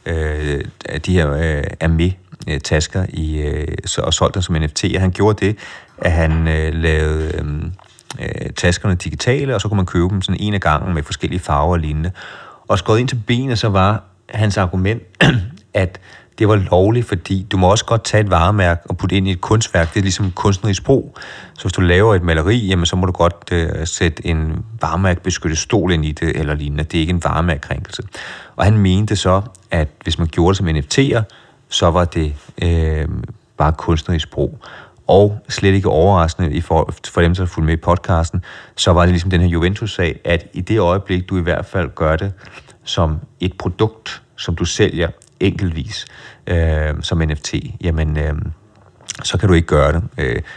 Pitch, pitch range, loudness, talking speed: 90 Hz, 80-100 Hz, -17 LUFS, 190 wpm